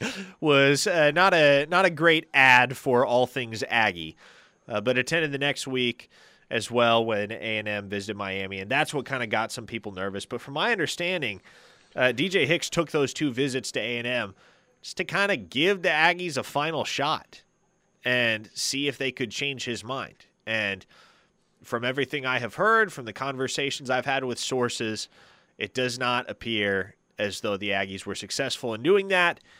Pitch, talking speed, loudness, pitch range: 125 Hz, 190 wpm, -25 LUFS, 110-145 Hz